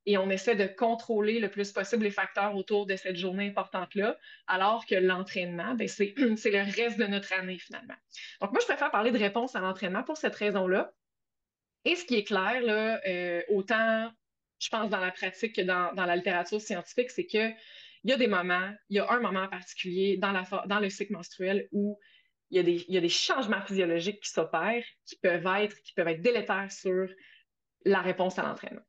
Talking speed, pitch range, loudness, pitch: 205 wpm, 185-225 Hz, -30 LUFS, 200 Hz